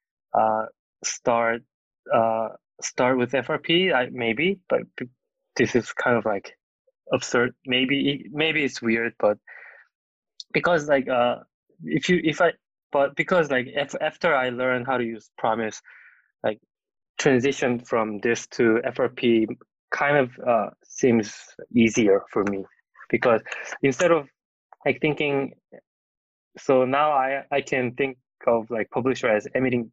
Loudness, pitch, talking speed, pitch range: -24 LUFS, 130 Hz, 135 wpm, 115-145 Hz